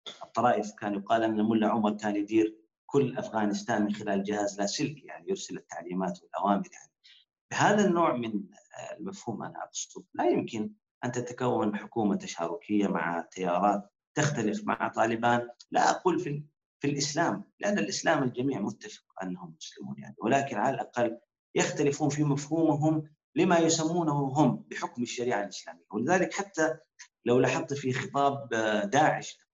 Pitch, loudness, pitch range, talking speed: 120 Hz, -29 LUFS, 105-145 Hz, 135 wpm